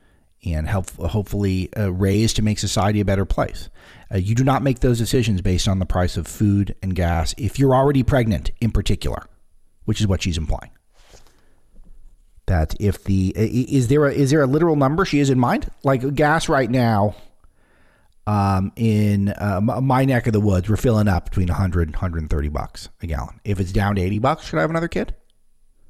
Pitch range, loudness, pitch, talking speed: 90-120 Hz, -20 LUFS, 105 Hz, 195 wpm